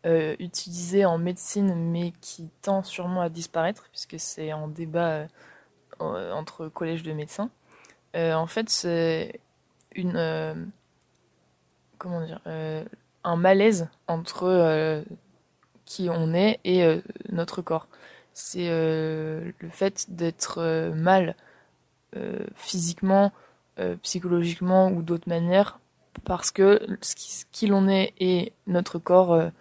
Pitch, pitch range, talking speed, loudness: 175 Hz, 165-190 Hz, 130 wpm, -25 LUFS